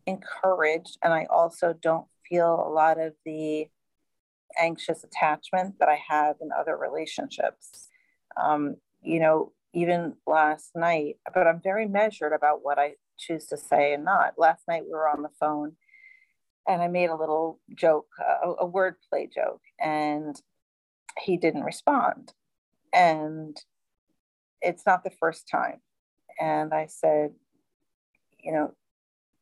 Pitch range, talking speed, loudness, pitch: 150-175 Hz, 140 wpm, -26 LUFS, 160 Hz